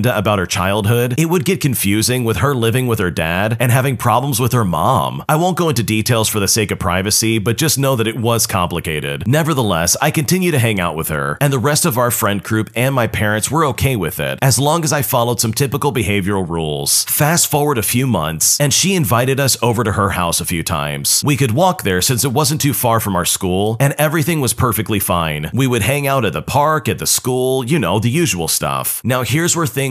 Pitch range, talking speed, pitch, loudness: 100-140 Hz, 240 wpm, 120 Hz, -15 LUFS